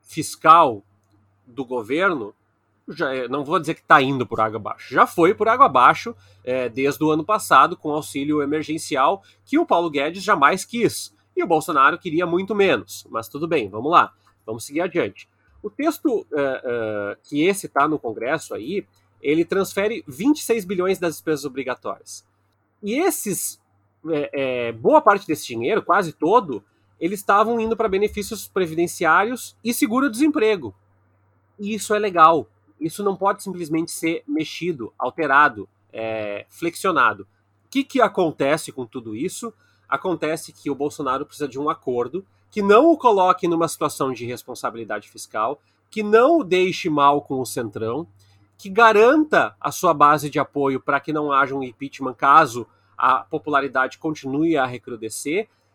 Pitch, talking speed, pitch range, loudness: 150 Hz, 155 wpm, 125-195 Hz, -20 LUFS